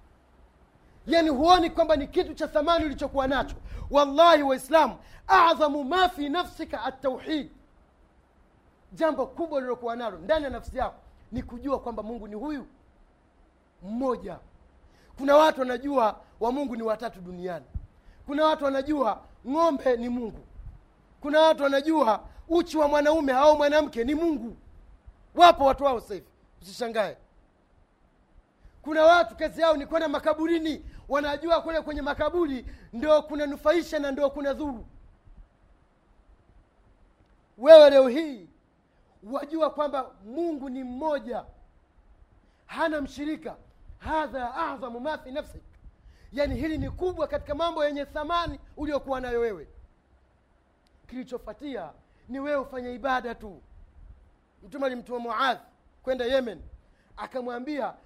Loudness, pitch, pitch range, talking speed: -25 LUFS, 275 Hz, 230-305 Hz, 120 wpm